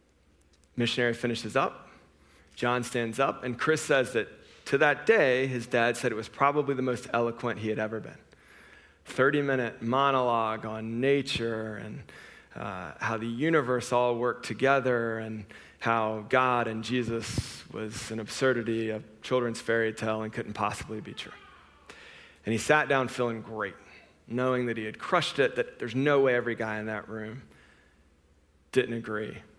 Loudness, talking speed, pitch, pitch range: -29 LUFS, 160 wpm, 115 Hz, 110-125 Hz